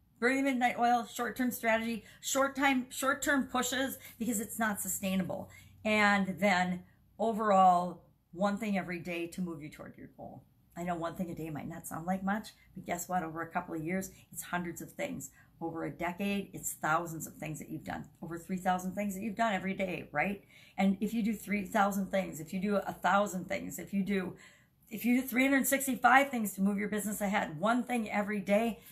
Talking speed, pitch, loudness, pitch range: 205 wpm, 200 Hz, -32 LUFS, 180-225 Hz